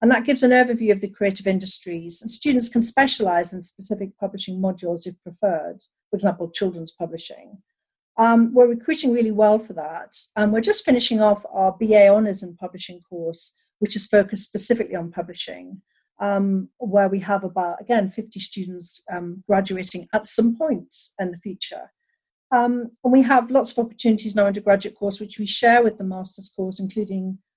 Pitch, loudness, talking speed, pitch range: 205 Hz, -21 LUFS, 180 wpm, 185-230 Hz